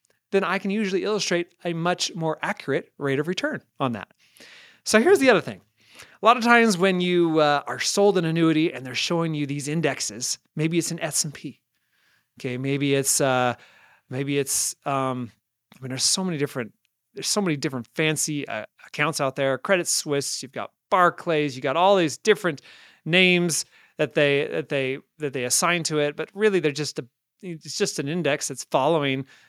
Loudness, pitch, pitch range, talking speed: -23 LUFS, 155 Hz, 135-175 Hz, 190 wpm